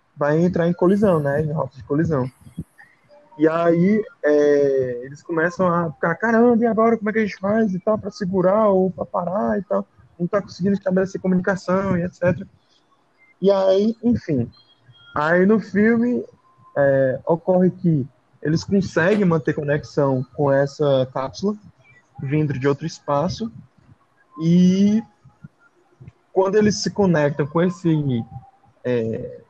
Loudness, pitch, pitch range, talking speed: -20 LUFS, 170 Hz, 140-200 Hz, 140 wpm